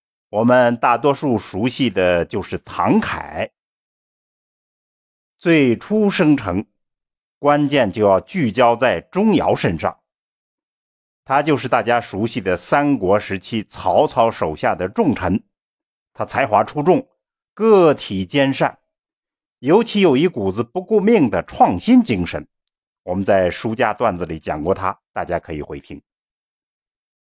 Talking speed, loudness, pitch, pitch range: 190 characters per minute, -18 LUFS, 120 Hz, 95-160 Hz